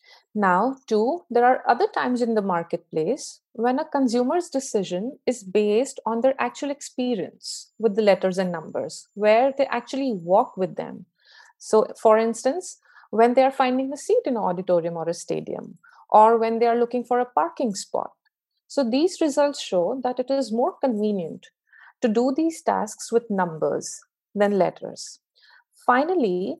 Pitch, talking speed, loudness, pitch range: 245 Hz, 160 wpm, -23 LUFS, 210-280 Hz